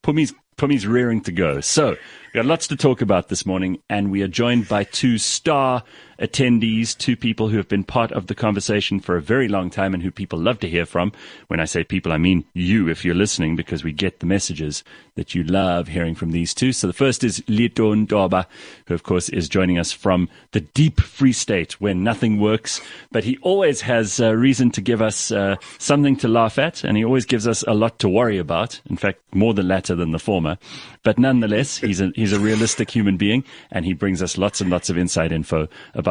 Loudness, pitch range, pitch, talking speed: -20 LUFS, 90-120 Hz, 105 Hz, 230 wpm